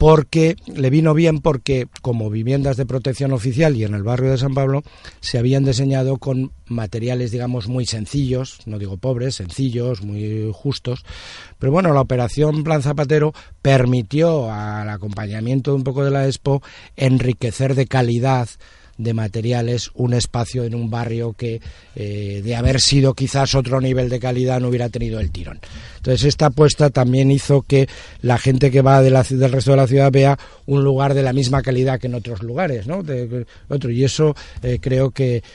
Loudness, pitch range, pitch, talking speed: -18 LUFS, 120-135 Hz, 130 Hz, 180 wpm